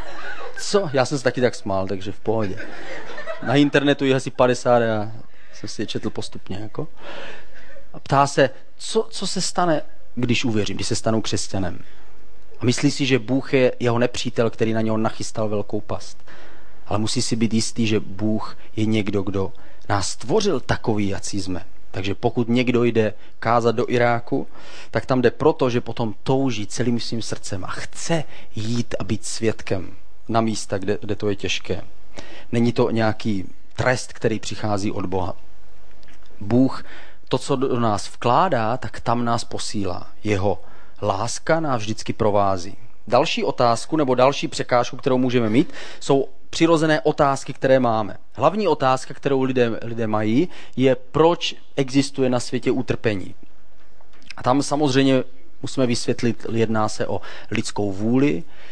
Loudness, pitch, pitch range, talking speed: -22 LUFS, 120 Hz, 105-130 Hz, 155 wpm